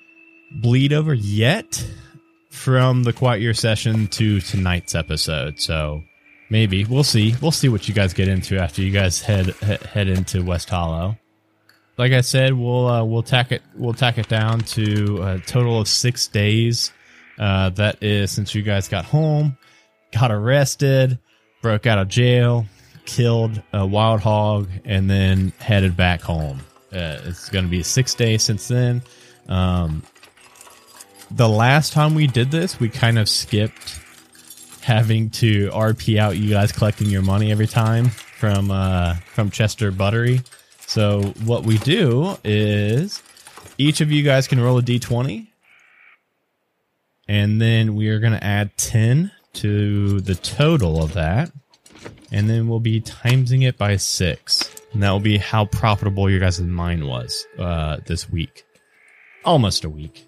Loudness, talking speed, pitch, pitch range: -19 LUFS, 155 wpm, 110 Hz, 95-120 Hz